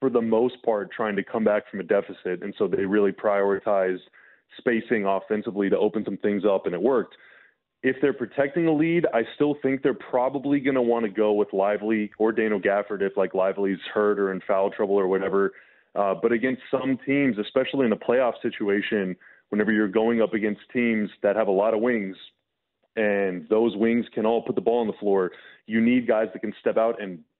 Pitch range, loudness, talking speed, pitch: 100-120 Hz, -24 LUFS, 210 wpm, 110 Hz